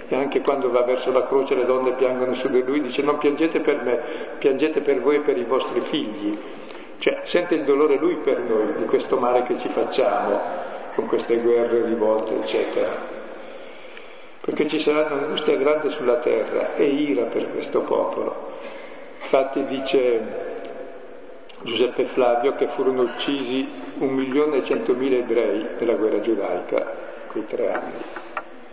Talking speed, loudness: 160 wpm, -22 LUFS